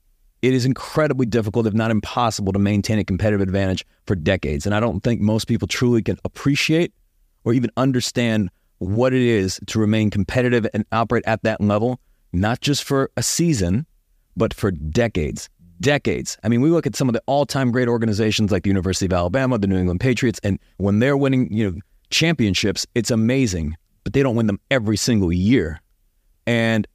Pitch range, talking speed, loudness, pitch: 95-125 Hz, 185 wpm, -20 LUFS, 110 Hz